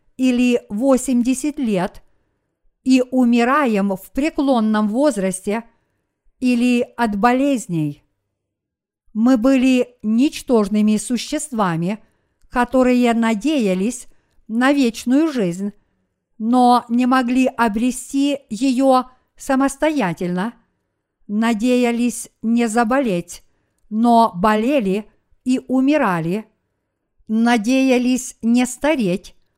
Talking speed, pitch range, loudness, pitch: 75 wpm, 210-260 Hz, -18 LUFS, 240 Hz